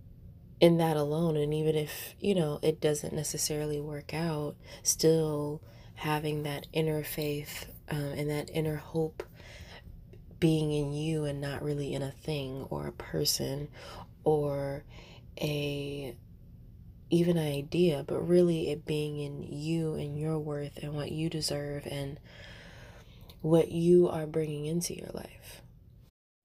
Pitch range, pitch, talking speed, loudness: 140-160 Hz, 150 Hz, 140 wpm, -31 LUFS